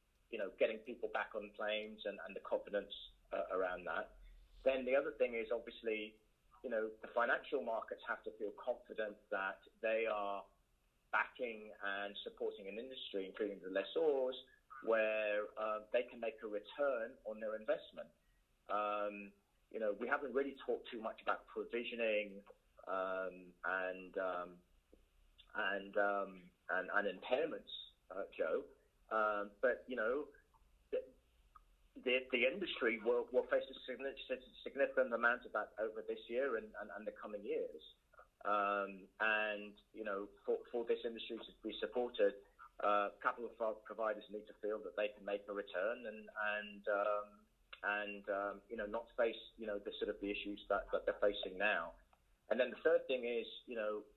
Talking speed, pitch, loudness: 165 wpm, 105 Hz, -41 LUFS